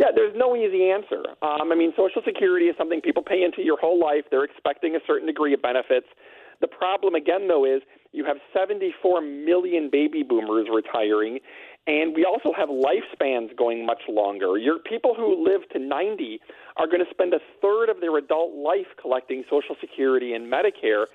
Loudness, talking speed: -23 LUFS, 185 wpm